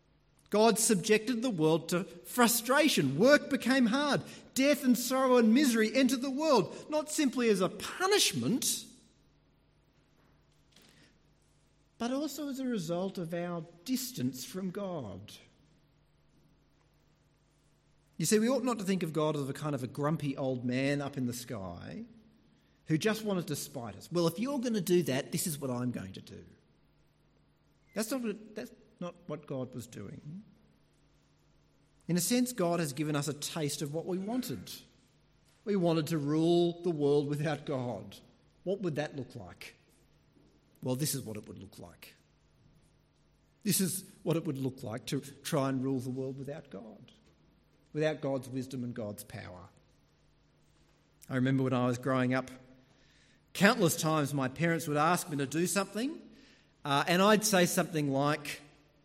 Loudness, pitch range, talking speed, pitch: -31 LUFS, 135-210 Hz, 165 wpm, 160 Hz